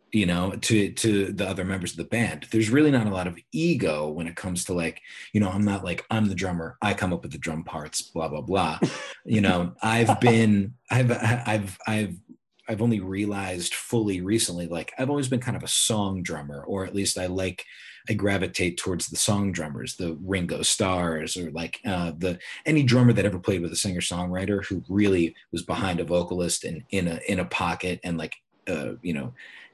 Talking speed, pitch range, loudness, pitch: 210 wpm, 90-110 Hz, -26 LUFS, 95 Hz